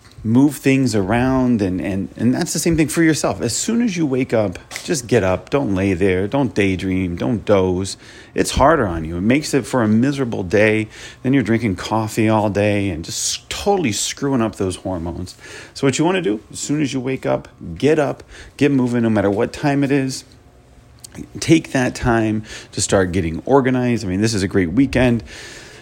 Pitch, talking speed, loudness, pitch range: 115 Hz, 205 wpm, -18 LUFS, 100-135 Hz